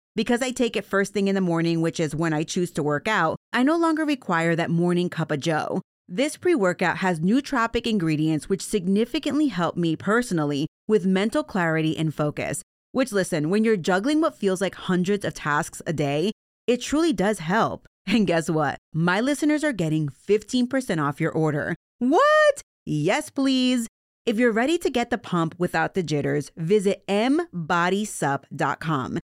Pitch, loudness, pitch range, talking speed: 190 Hz, -23 LUFS, 160-240 Hz, 170 wpm